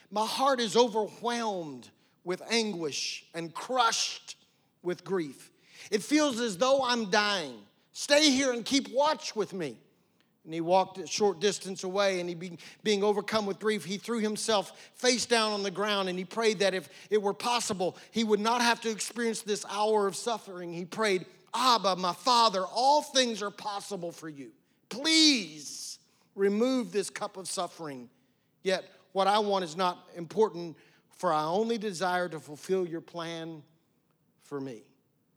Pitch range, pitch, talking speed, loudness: 180-225 Hz, 200 Hz, 165 wpm, -29 LUFS